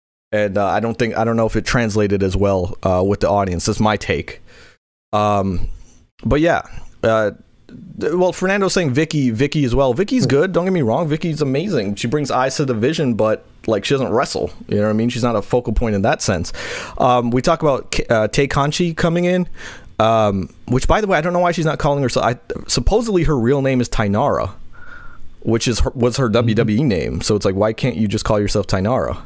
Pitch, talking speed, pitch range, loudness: 120 Hz, 220 wpm, 105-145 Hz, -18 LUFS